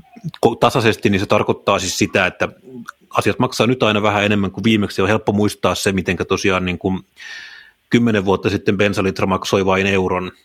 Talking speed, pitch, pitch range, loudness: 170 wpm, 100 Hz, 95-110 Hz, -17 LUFS